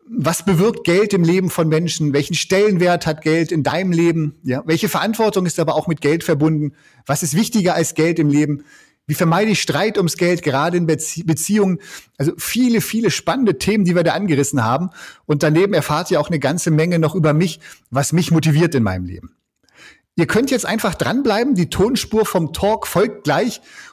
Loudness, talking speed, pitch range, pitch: -17 LUFS, 195 wpm, 155-195 Hz, 170 Hz